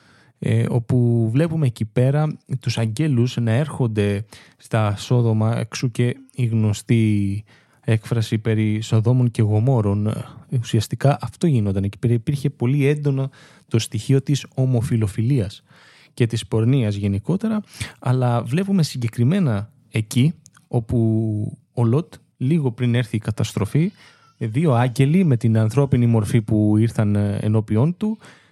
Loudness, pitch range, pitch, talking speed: -20 LUFS, 110-140 Hz, 120 Hz, 120 wpm